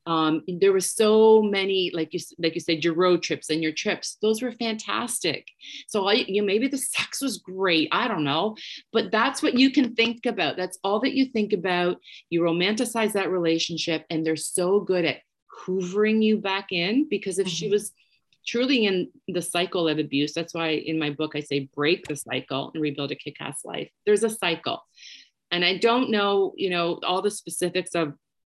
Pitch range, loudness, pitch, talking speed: 165-215 Hz, -24 LUFS, 185 Hz, 200 wpm